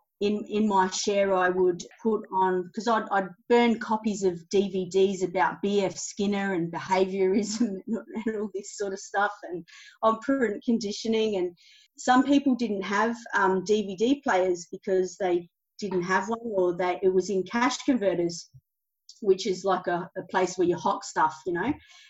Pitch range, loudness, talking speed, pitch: 185-220 Hz, -27 LUFS, 170 wpm, 195 Hz